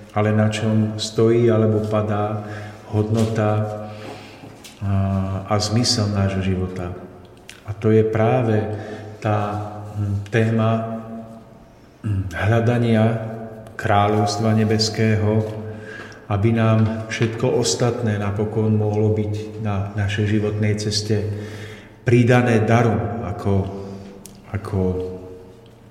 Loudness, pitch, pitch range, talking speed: -20 LUFS, 105 Hz, 105-110 Hz, 80 wpm